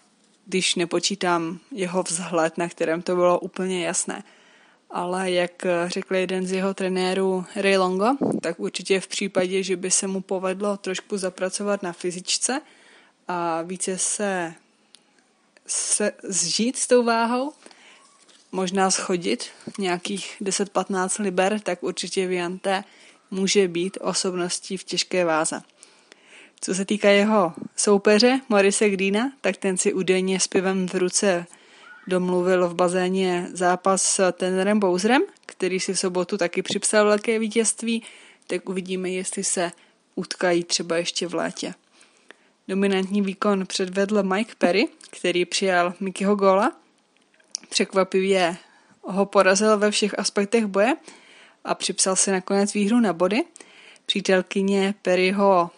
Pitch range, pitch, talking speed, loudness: 180-205 Hz, 190 Hz, 125 wpm, -23 LUFS